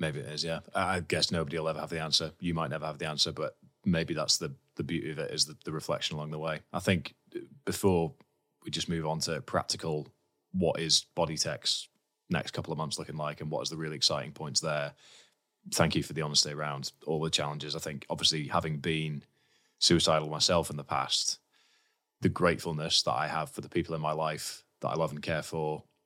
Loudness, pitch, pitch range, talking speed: -31 LUFS, 80 Hz, 75-80 Hz, 220 wpm